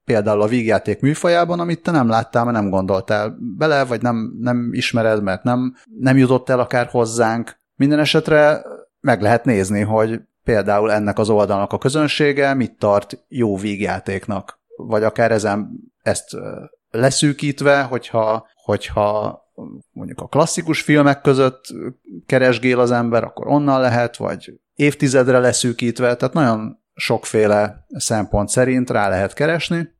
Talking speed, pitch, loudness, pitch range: 135 wpm, 120 Hz, -17 LUFS, 105-140 Hz